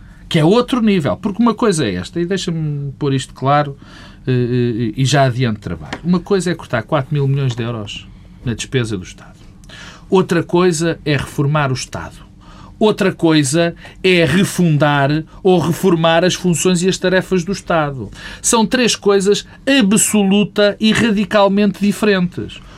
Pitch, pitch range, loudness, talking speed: 170 Hz, 140-195 Hz, -15 LUFS, 150 wpm